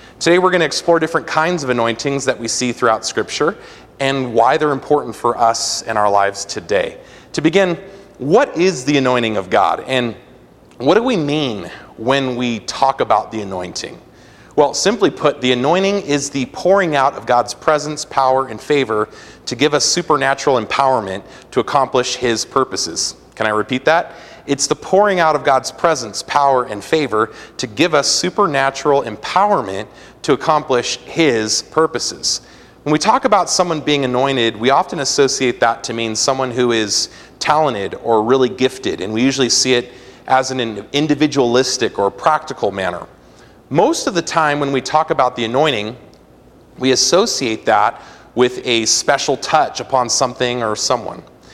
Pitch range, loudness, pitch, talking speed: 115-150 Hz, -16 LUFS, 130 Hz, 165 wpm